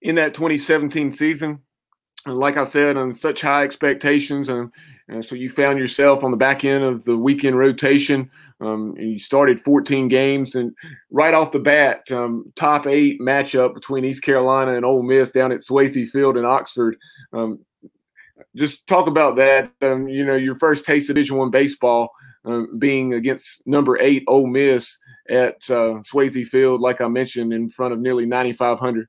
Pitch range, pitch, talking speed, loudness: 125-140 Hz, 135 Hz, 175 wpm, -18 LUFS